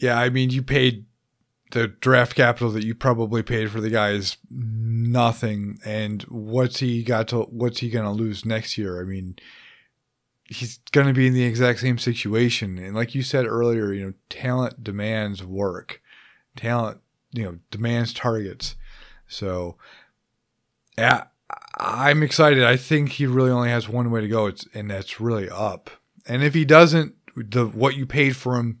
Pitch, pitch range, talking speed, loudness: 120 Hz, 110-125 Hz, 170 wpm, -22 LUFS